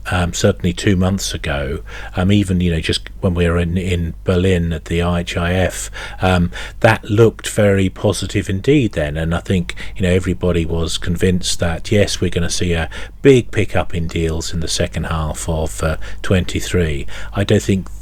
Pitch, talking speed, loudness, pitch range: 90 Hz, 185 wpm, -18 LUFS, 85-100 Hz